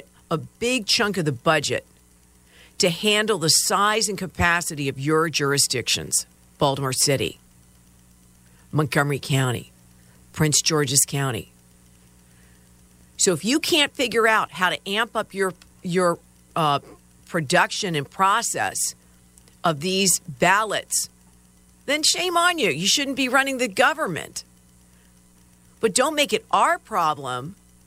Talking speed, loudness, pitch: 125 wpm, -21 LUFS, 140 Hz